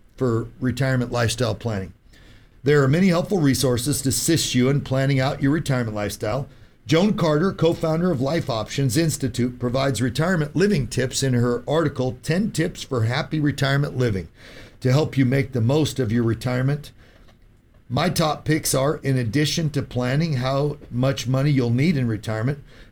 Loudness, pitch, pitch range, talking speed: -22 LUFS, 130 Hz, 120-145 Hz, 165 wpm